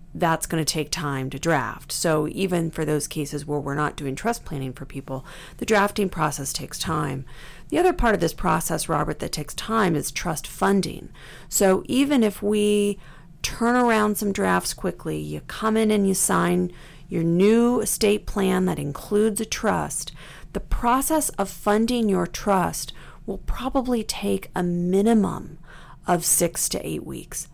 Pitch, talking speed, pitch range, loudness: 175 Hz, 170 wpm, 150-210 Hz, -23 LUFS